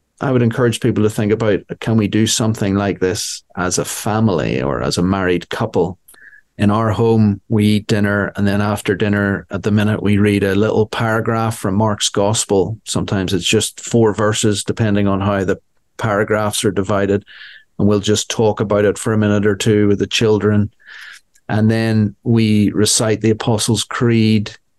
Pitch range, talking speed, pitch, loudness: 100-110 Hz, 180 wpm, 105 Hz, -16 LUFS